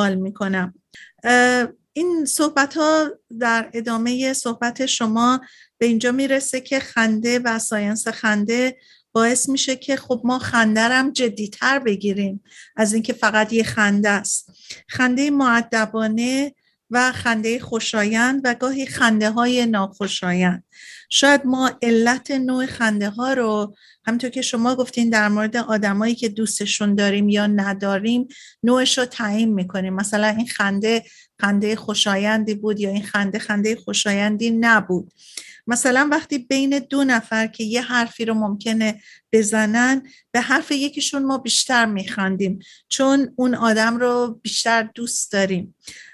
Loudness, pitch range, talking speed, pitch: -19 LUFS, 210-255 Hz, 130 wpm, 230 Hz